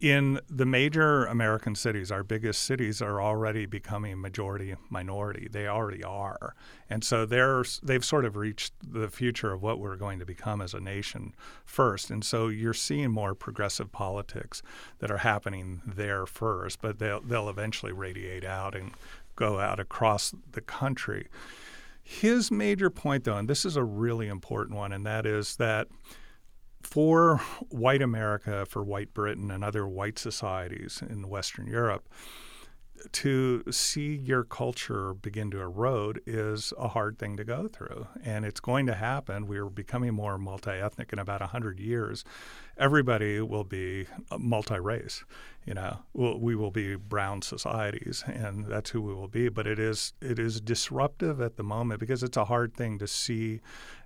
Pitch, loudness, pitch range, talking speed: 110 Hz, -30 LUFS, 100-120 Hz, 165 wpm